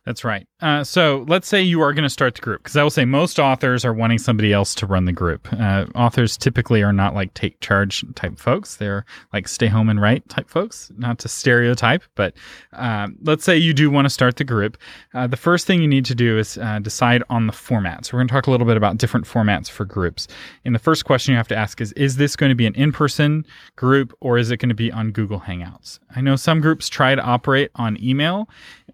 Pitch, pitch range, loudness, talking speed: 120 Hz, 110-140 Hz, -18 LUFS, 255 wpm